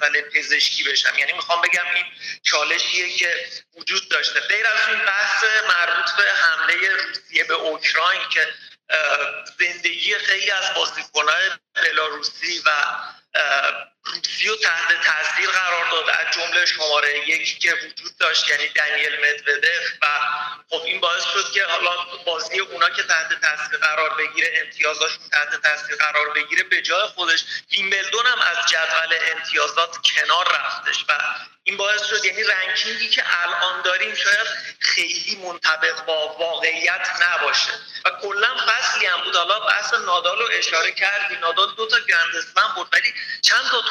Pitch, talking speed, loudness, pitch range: 175 Hz, 145 wpm, -19 LUFS, 160-215 Hz